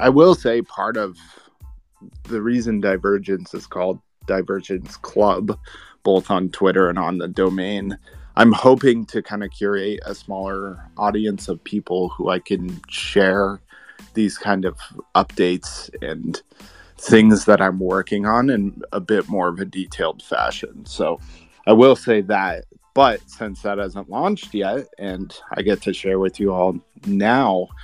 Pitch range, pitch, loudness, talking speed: 95-105 Hz, 100 Hz, -19 LUFS, 155 wpm